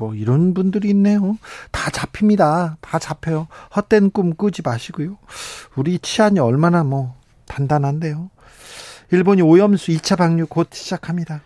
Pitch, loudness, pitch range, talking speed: 170 Hz, -18 LUFS, 155-200 Hz, 295 characters per minute